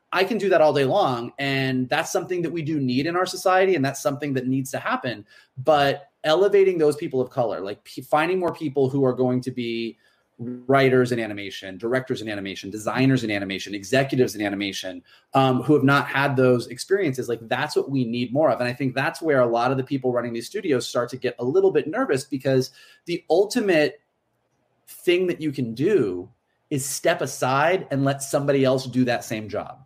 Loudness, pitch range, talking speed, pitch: -23 LUFS, 120-150 Hz, 210 wpm, 130 Hz